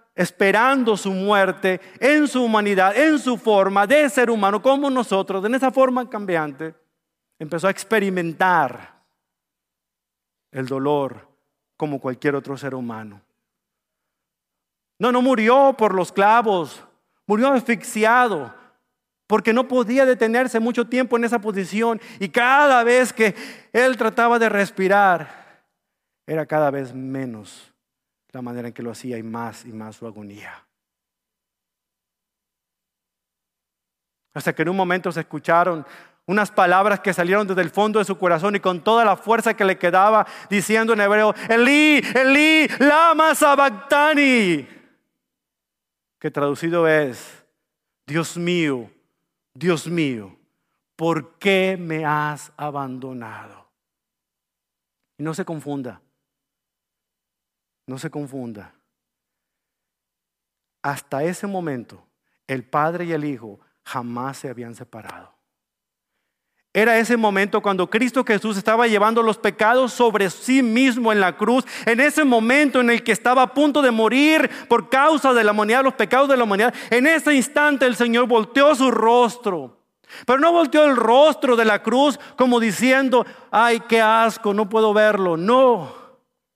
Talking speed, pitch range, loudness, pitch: 135 wpm, 160-245 Hz, -18 LUFS, 215 Hz